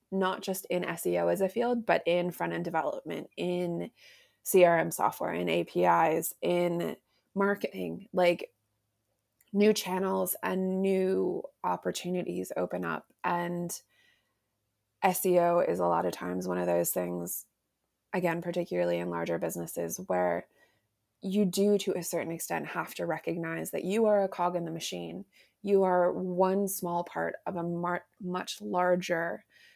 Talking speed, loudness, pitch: 145 wpm, -30 LUFS, 170 Hz